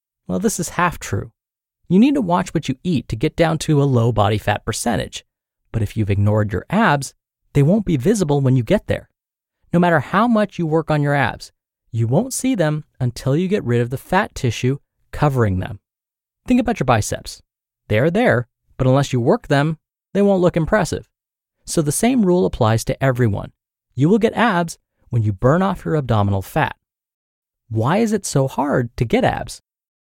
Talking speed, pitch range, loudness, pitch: 200 wpm, 120-175 Hz, -18 LUFS, 140 Hz